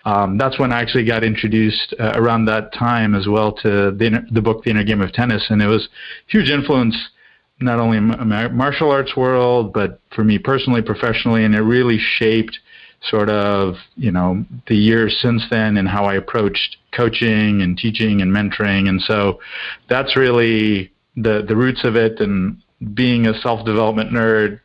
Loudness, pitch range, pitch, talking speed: -17 LUFS, 105-120 Hz, 110 Hz, 185 wpm